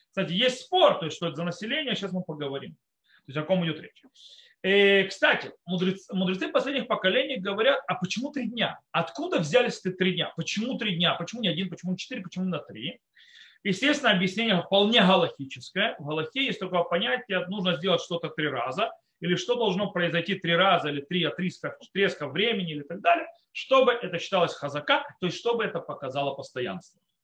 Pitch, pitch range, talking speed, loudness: 185 Hz, 170-225 Hz, 195 wpm, -26 LUFS